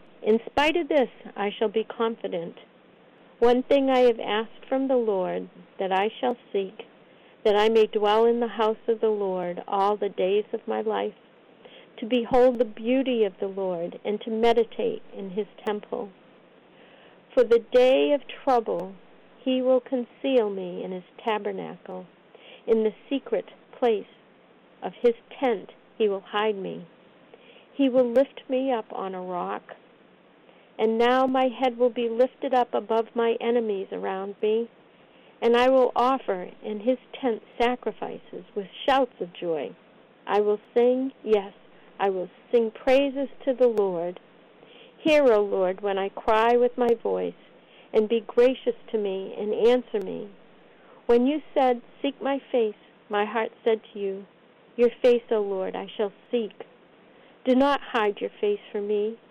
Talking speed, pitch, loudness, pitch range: 160 wpm, 230 Hz, -25 LUFS, 205-250 Hz